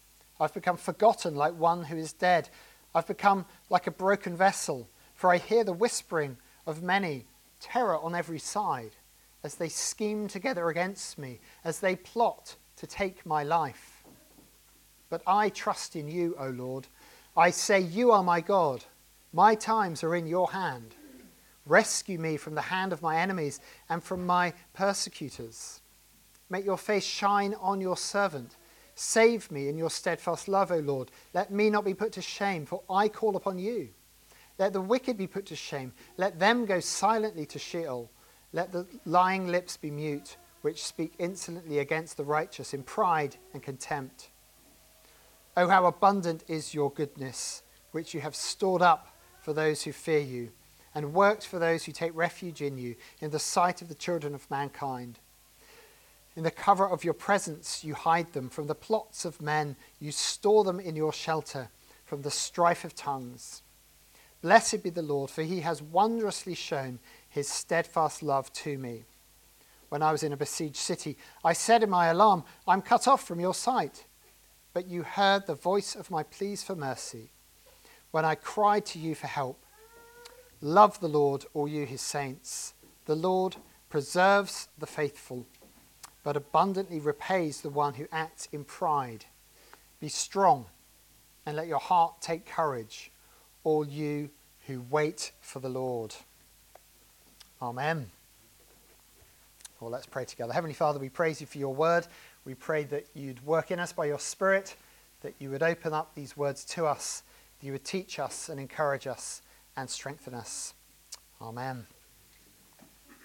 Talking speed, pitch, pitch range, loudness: 165 wpm, 165 Hz, 145-190 Hz, -30 LUFS